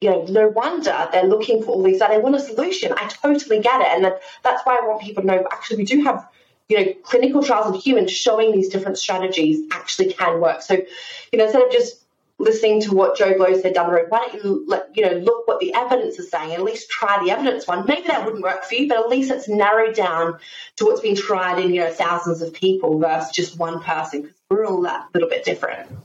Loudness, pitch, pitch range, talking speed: -19 LUFS, 215 Hz, 185-280 Hz, 255 wpm